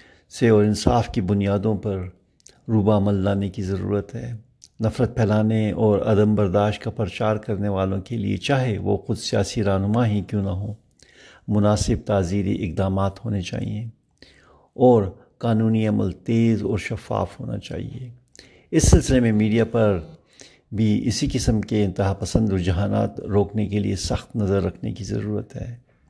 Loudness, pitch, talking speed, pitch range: -22 LUFS, 105 Hz, 150 wpm, 100-115 Hz